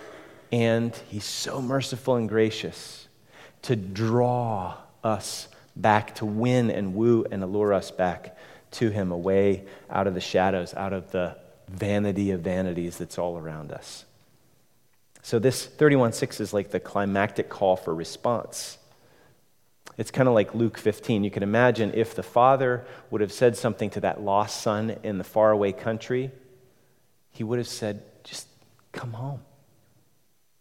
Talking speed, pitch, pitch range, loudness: 150 wpm, 110 Hz, 100-120 Hz, -26 LUFS